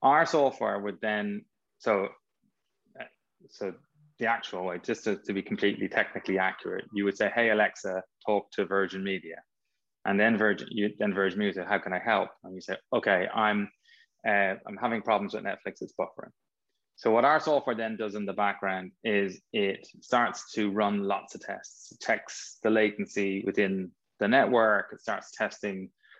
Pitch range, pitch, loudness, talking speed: 95-110 Hz, 100 Hz, -29 LUFS, 175 wpm